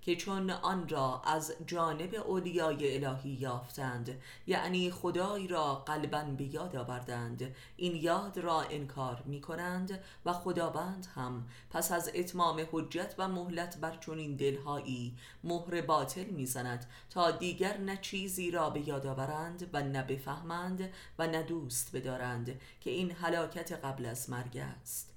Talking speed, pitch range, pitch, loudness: 145 wpm, 130-175 Hz, 160 Hz, -37 LUFS